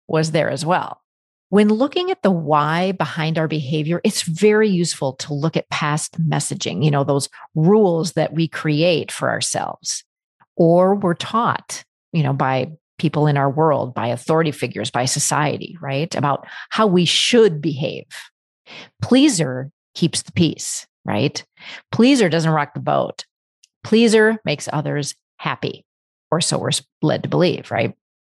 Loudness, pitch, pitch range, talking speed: -19 LUFS, 160 Hz, 145-190 Hz, 150 wpm